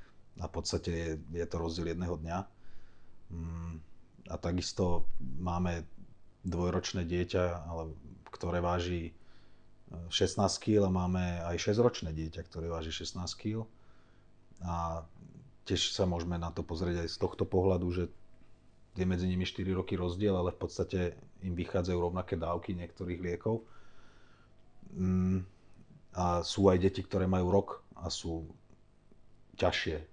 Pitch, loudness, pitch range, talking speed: 90 Hz, -34 LUFS, 85-95 Hz, 125 wpm